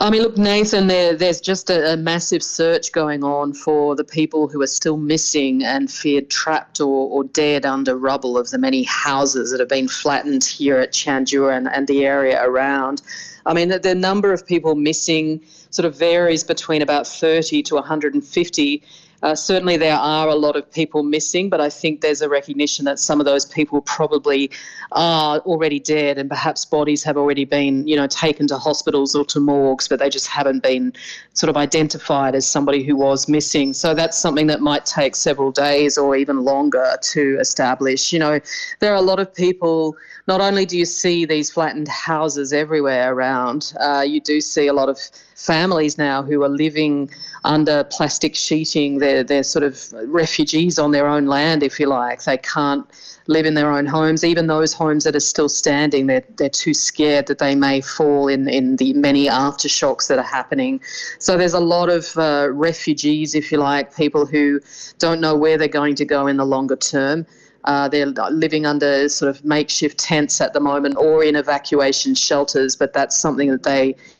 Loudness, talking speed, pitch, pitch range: -17 LUFS, 195 wpm, 150 Hz, 140-160 Hz